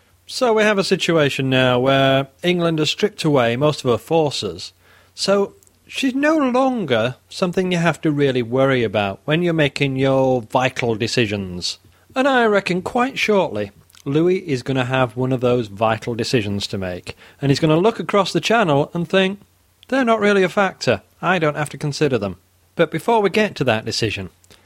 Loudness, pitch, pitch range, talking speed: -19 LUFS, 140 Hz, 115-185 Hz, 185 wpm